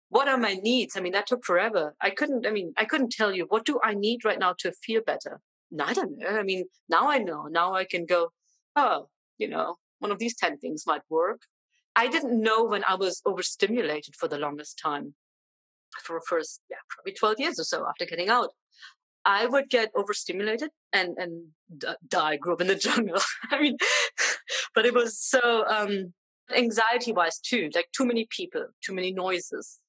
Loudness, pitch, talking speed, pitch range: -27 LUFS, 215 Hz, 200 wpm, 185-250 Hz